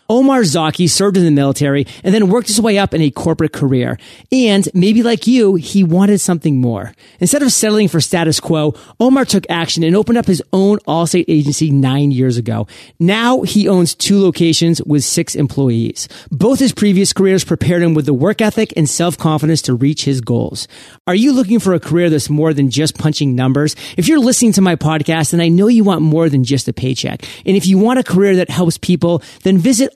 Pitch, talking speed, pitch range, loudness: 170 Hz, 215 wpm, 150-200 Hz, -13 LUFS